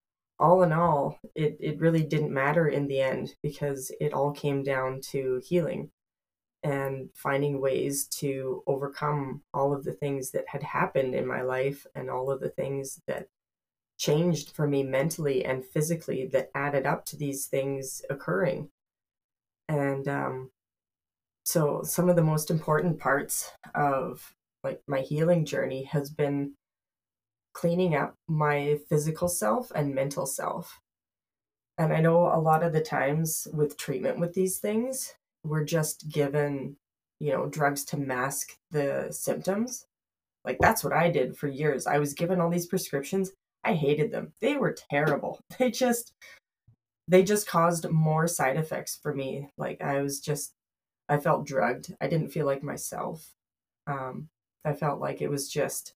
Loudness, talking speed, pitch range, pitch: -28 LUFS, 160 wpm, 135-165 Hz, 145 Hz